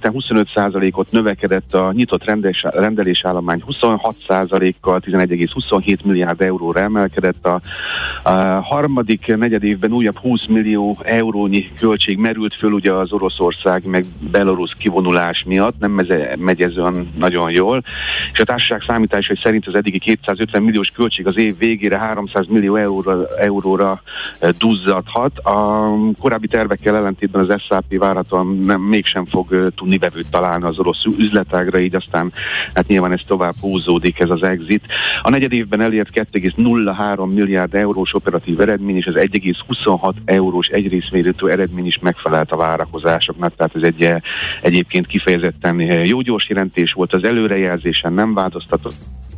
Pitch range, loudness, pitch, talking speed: 90-105 Hz, -16 LUFS, 95 Hz, 145 wpm